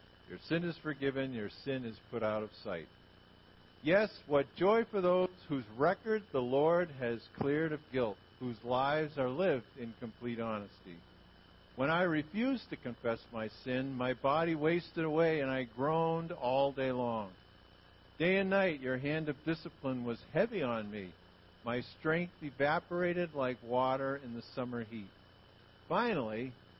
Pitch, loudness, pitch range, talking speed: 130 Hz, -35 LUFS, 115-160 Hz, 155 wpm